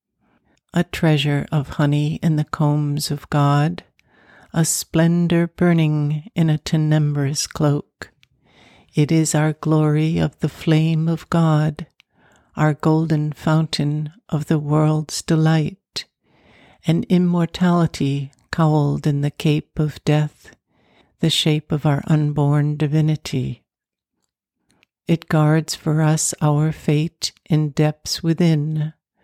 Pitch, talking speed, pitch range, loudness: 155 Hz, 115 wpm, 150-160 Hz, -19 LUFS